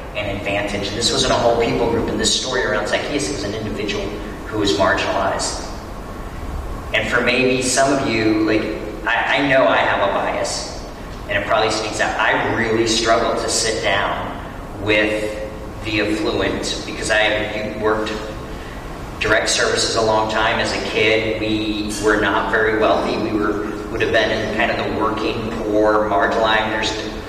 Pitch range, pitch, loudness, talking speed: 105-110 Hz, 110 Hz, -18 LUFS, 170 wpm